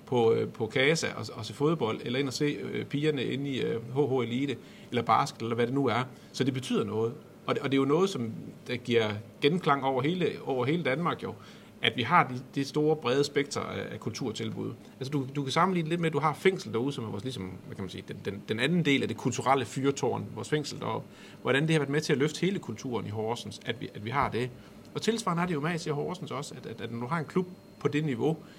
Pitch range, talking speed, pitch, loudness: 120-150 Hz, 260 wpm, 140 Hz, -30 LUFS